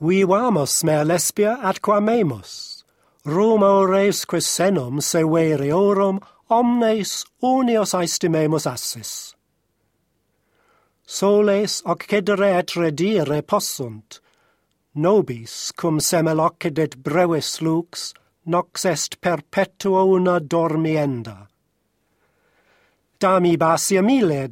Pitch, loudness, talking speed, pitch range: 175 Hz, -19 LUFS, 85 wpm, 155-200 Hz